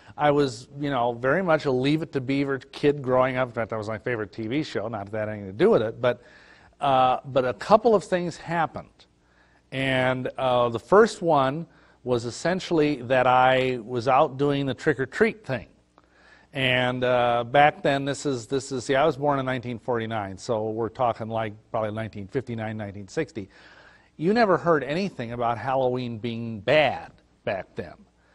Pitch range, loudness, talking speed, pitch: 115-145 Hz, -24 LUFS, 175 wpm, 130 Hz